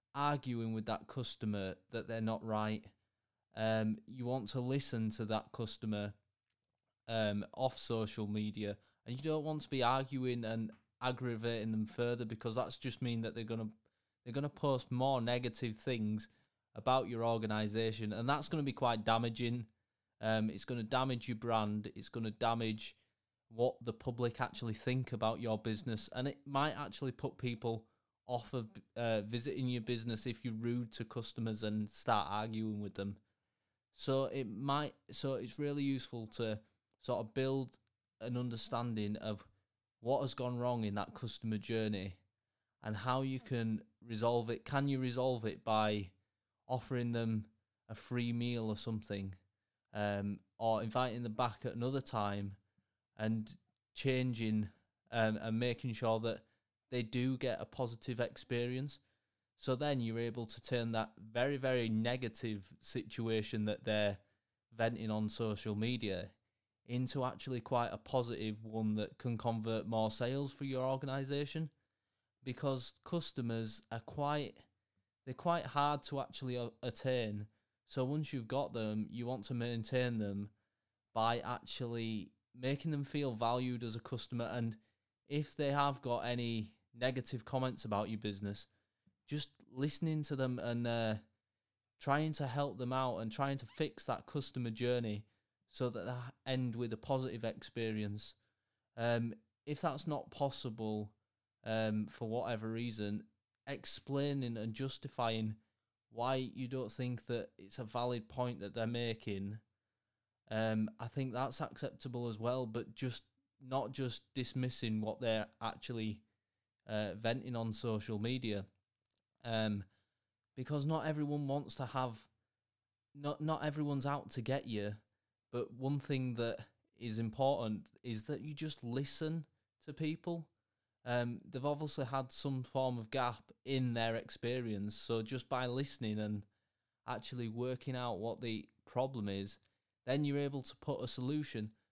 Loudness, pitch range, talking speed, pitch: -40 LUFS, 110-130 Hz, 150 wpm, 115 Hz